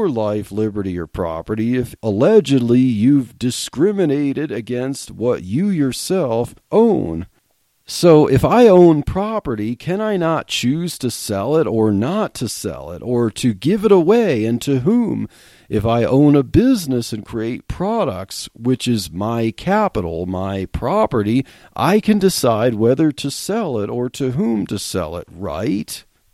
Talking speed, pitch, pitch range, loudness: 150 wpm, 125 Hz, 110-160 Hz, -17 LUFS